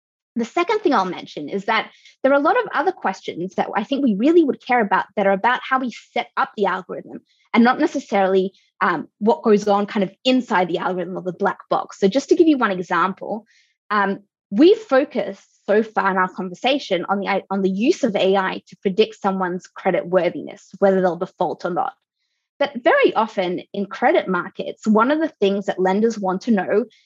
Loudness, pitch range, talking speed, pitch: -20 LUFS, 190-260 Hz, 210 wpm, 205 Hz